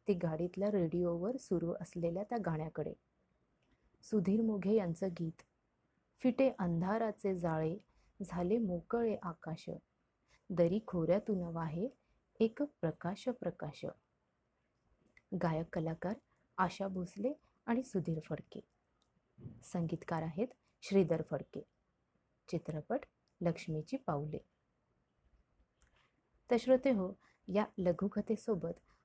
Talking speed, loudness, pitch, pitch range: 80 wpm, -38 LUFS, 185 Hz, 165-215 Hz